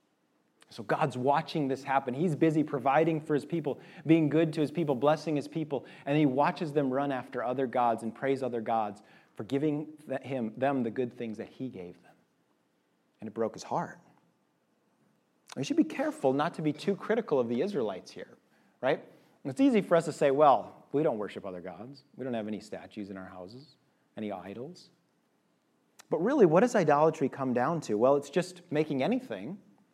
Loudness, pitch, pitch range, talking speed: -30 LUFS, 140 Hz, 125-160 Hz, 190 wpm